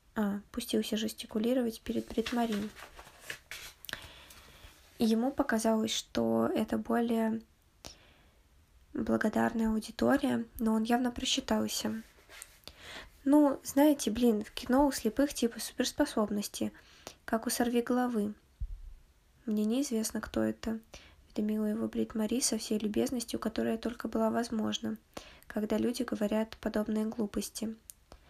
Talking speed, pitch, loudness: 105 wpm, 220 Hz, -32 LUFS